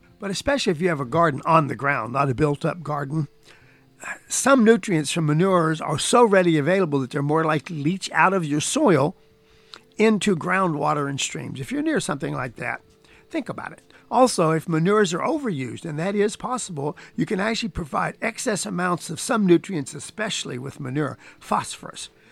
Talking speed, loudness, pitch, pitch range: 185 wpm, -22 LUFS, 170 Hz, 150-200 Hz